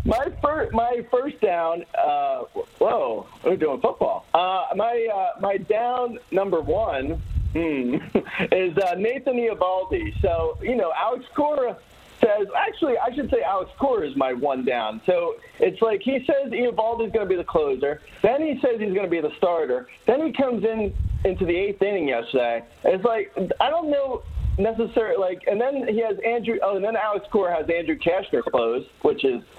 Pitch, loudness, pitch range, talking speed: 230 Hz, -23 LUFS, 190-300 Hz, 185 wpm